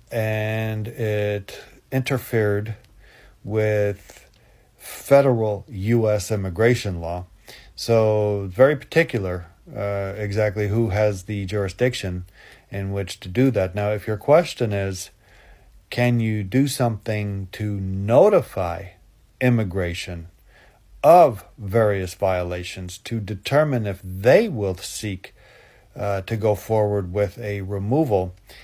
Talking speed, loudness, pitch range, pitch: 105 wpm, -22 LUFS, 95-115 Hz, 105 Hz